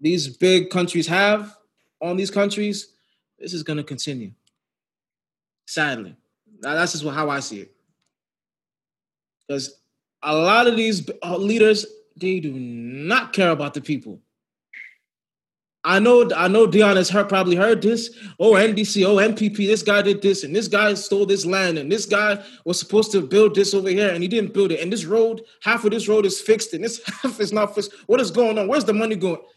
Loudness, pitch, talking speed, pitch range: -19 LUFS, 200 Hz, 190 wpm, 175-215 Hz